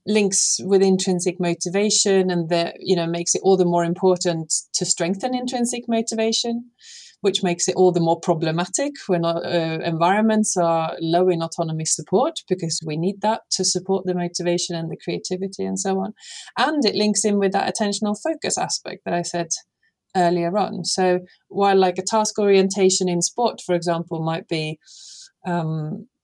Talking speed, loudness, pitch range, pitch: 170 wpm, -21 LUFS, 170-210 Hz, 185 Hz